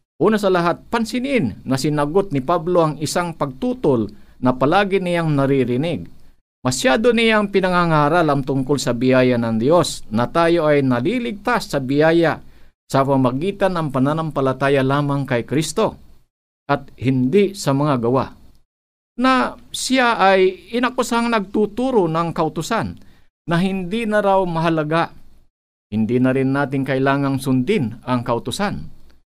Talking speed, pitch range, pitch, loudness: 125 wpm, 130-190 Hz, 150 Hz, -18 LUFS